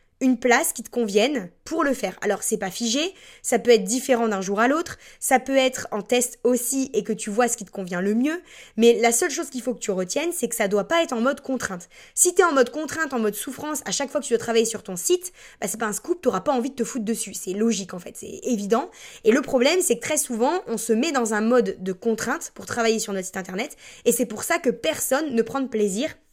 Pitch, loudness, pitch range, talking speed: 235 Hz, -23 LUFS, 215-265 Hz, 275 wpm